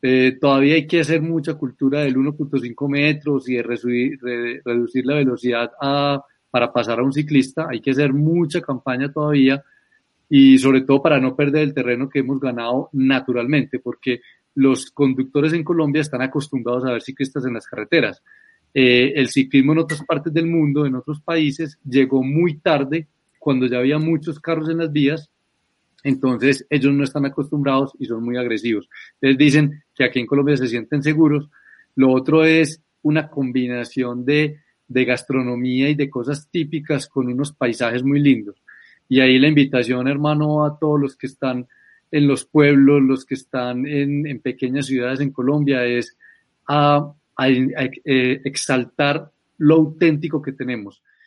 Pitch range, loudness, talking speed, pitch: 130-150 Hz, -19 LUFS, 165 wpm, 140 Hz